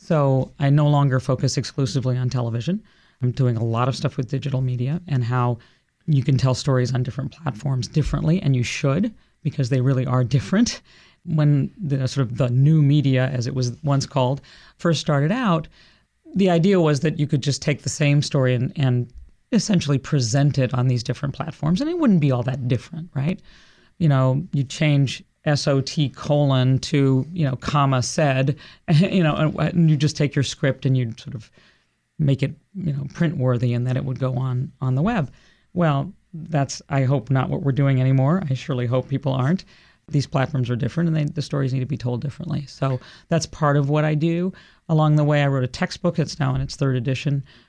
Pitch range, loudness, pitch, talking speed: 130-155 Hz, -21 LUFS, 140 Hz, 205 wpm